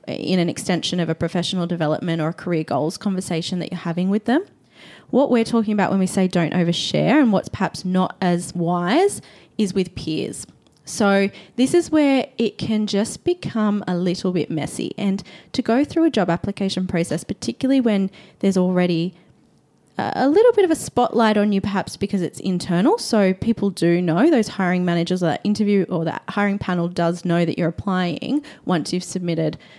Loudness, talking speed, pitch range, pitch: -20 LUFS, 185 wpm, 170-210 Hz, 185 Hz